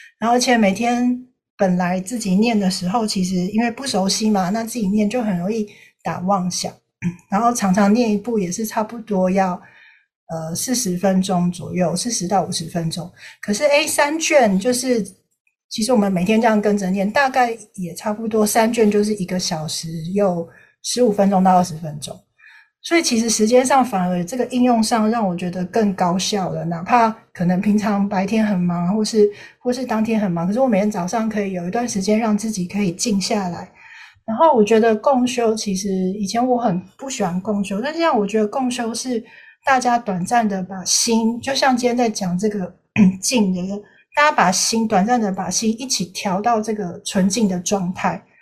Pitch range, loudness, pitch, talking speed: 185-235 Hz, -19 LUFS, 210 Hz, 285 characters per minute